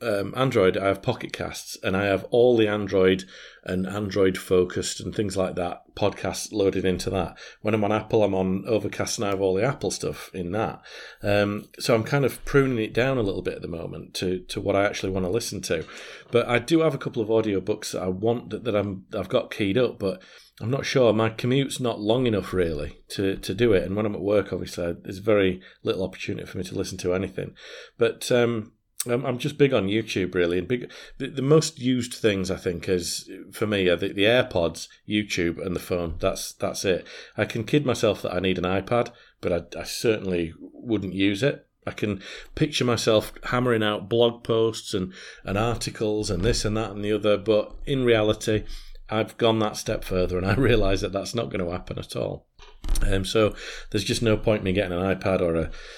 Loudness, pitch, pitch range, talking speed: -25 LUFS, 105 Hz, 95-115 Hz, 220 wpm